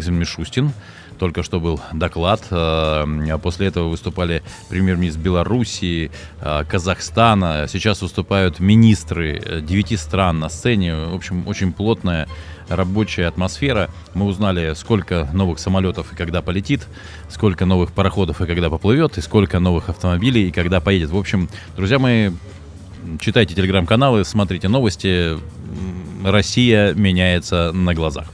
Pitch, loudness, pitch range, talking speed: 90 Hz, -18 LUFS, 85-100 Hz, 120 wpm